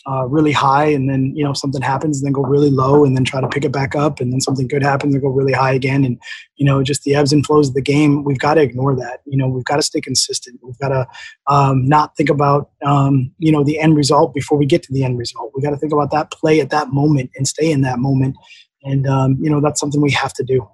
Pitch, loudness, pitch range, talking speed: 140 Hz, -16 LUFS, 135-150 Hz, 290 wpm